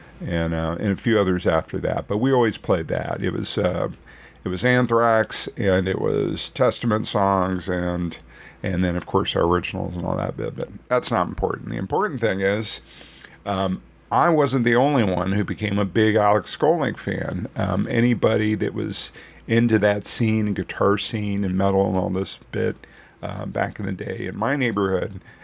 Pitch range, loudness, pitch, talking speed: 95-110 Hz, -22 LUFS, 100 Hz, 190 wpm